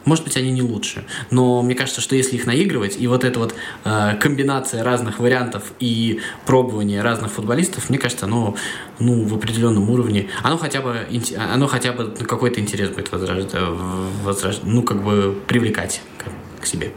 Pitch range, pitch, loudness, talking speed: 105-125 Hz, 120 Hz, -20 LUFS, 170 wpm